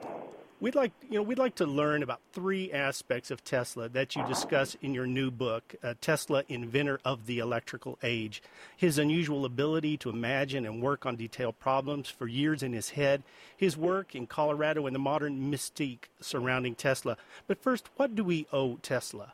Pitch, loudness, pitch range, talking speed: 140 Hz, -32 LUFS, 125-155 Hz, 185 wpm